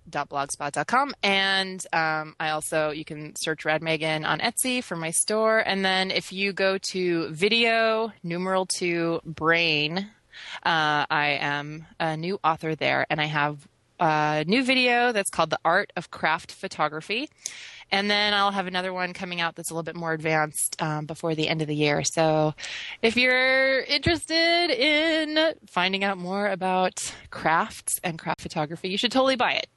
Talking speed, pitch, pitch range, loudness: 170 wpm, 175 Hz, 155-205 Hz, -24 LUFS